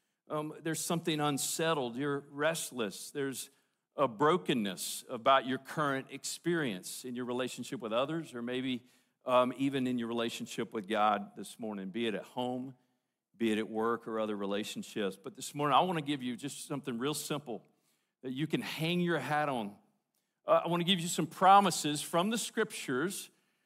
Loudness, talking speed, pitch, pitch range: -33 LUFS, 180 wpm, 140 Hz, 125-160 Hz